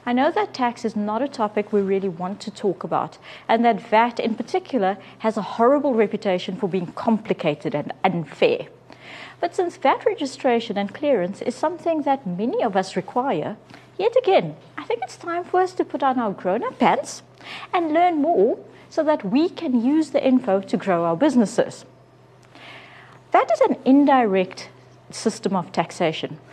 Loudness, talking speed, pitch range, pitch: -22 LUFS, 175 wpm, 195-305 Hz, 235 Hz